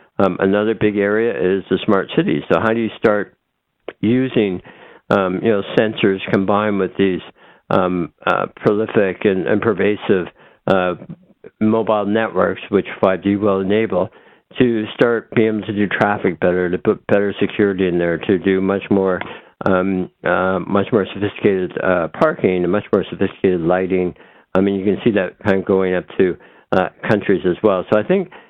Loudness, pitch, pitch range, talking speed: -17 LUFS, 100 Hz, 95-105 Hz, 175 wpm